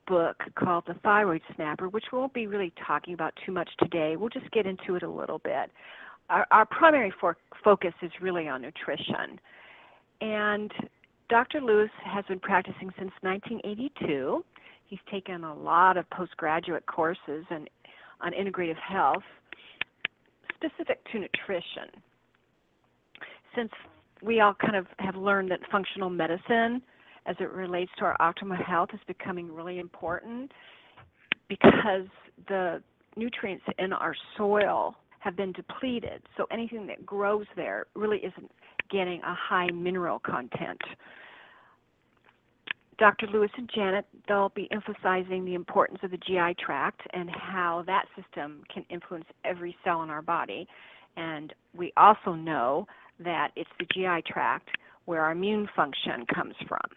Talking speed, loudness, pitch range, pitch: 140 wpm, -29 LUFS, 175-210 Hz, 190 Hz